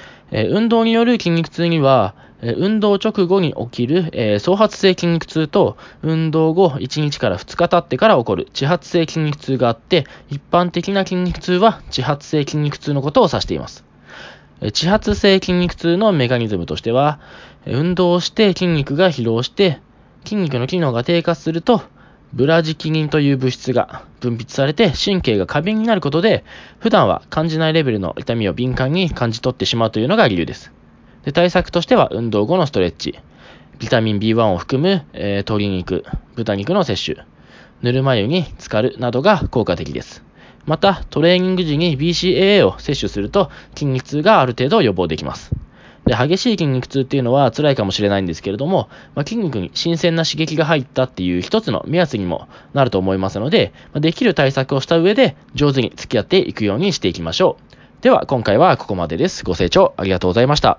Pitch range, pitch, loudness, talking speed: 115-175 Hz, 145 Hz, -17 LUFS, 370 characters per minute